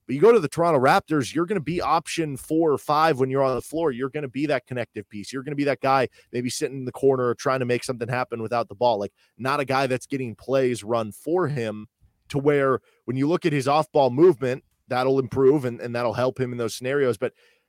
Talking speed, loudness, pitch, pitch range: 265 wpm, -23 LUFS, 135 Hz, 120-150 Hz